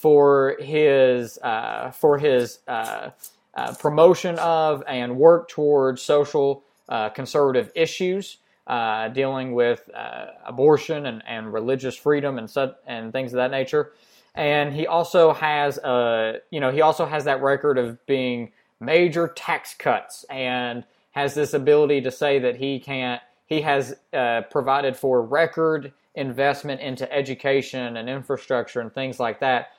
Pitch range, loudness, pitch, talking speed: 125-150 Hz, -22 LUFS, 140 Hz, 145 wpm